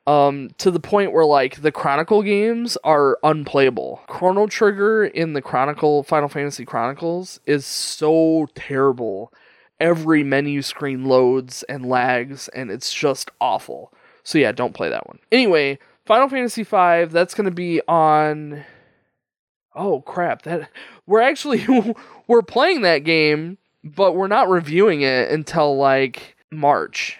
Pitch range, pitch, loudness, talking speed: 140-185 Hz, 155 Hz, -18 LUFS, 140 wpm